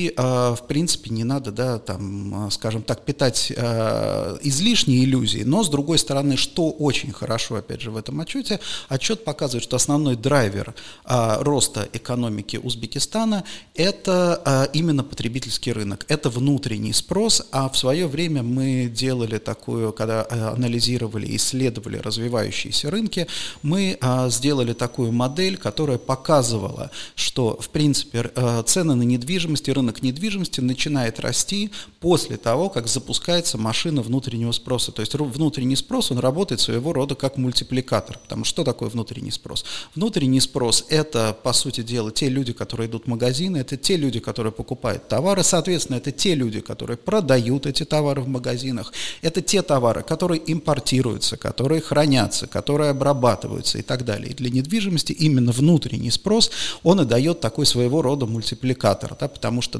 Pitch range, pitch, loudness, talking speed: 115-150 Hz, 130 Hz, -22 LUFS, 150 wpm